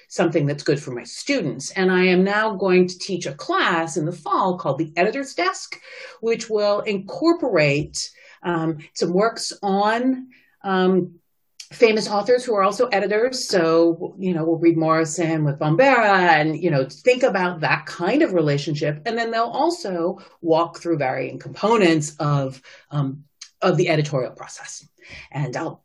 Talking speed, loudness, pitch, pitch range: 160 wpm, -20 LUFS, 175 Hz, 160-210 Hz